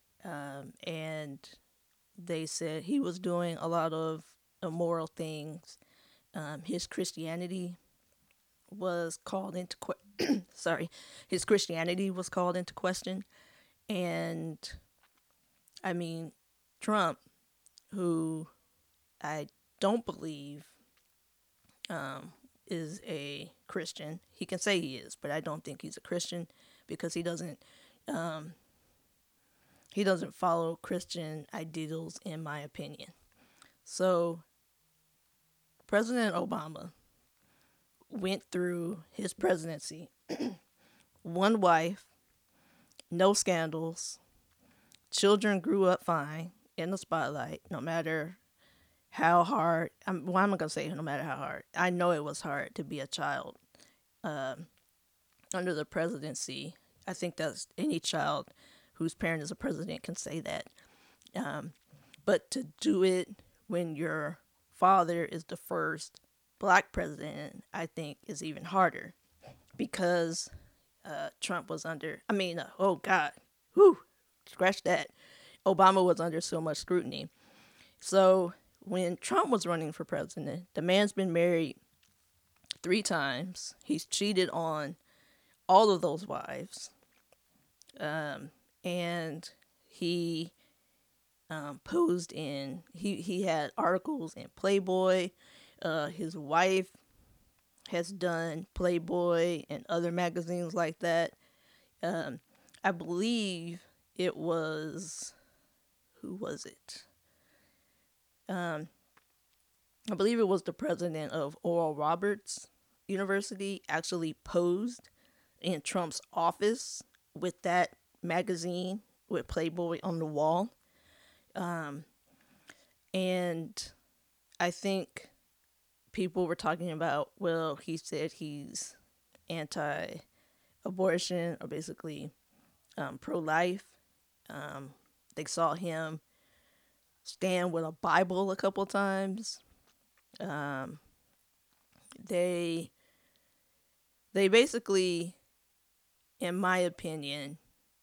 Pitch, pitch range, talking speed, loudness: 175 Hz, 160-190 Hz, 110 wpm, -33 LUFS